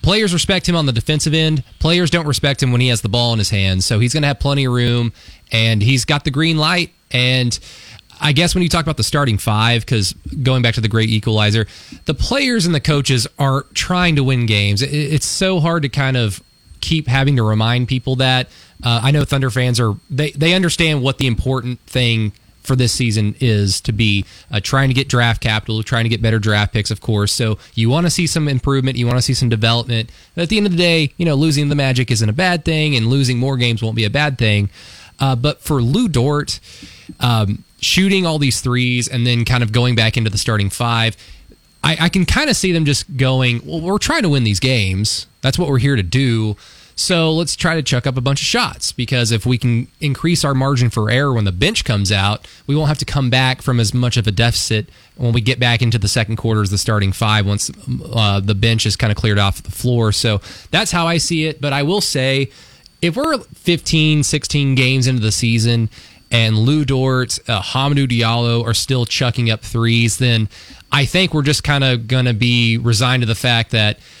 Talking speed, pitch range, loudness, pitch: 235 wpm, 110-145 Hz, -16 LUFS, 125 Hz